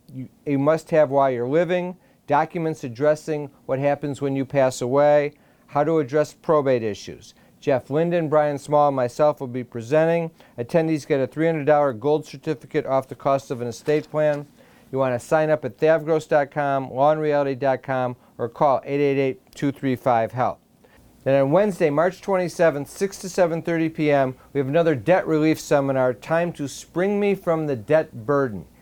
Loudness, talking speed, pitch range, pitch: -22 LUFS, 155 wpm, 135-160 Hz, 145 Hz